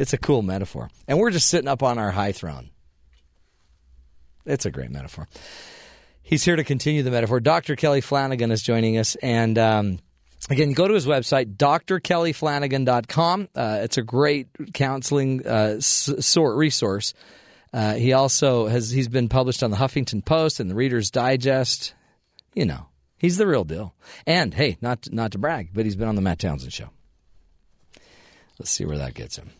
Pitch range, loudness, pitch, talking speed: 95-140 Hz, -22 LUFS, 125 Hz, 175 wpm